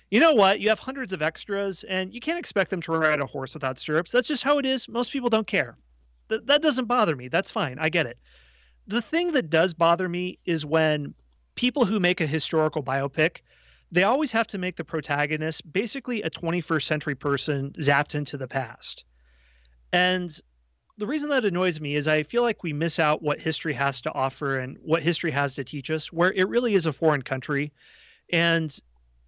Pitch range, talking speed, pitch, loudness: 140-200 Hz, 205 wpm, 160 Hz, -25 LUFS